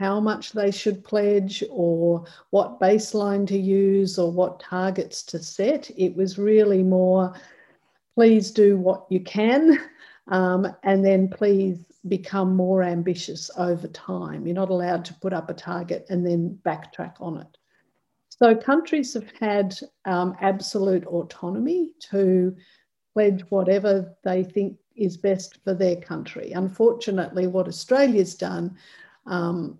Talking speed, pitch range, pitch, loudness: 135 wpm, 180-205 Hz, 190 Hz, -23 LUFS